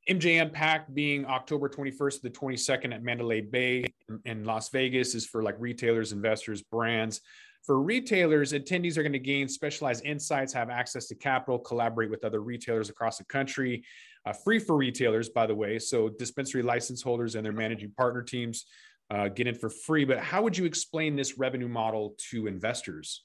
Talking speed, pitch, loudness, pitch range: 185 wpm, 125 Hz, -30 LUFS, 115-145 Hz